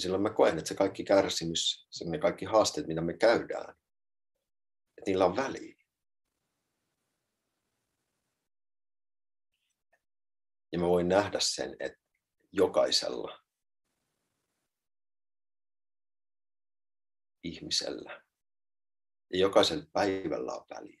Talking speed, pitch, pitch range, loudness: 90 wpm, 100 Hz, 85-100 Hz, -29 LUFS